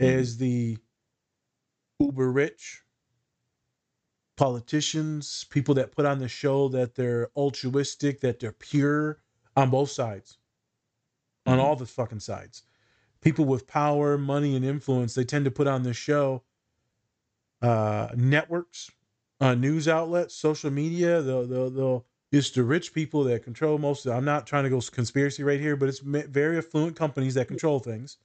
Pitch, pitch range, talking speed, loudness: 135 Hz, 120-145 Hz, 150 wpm, -26 LUFS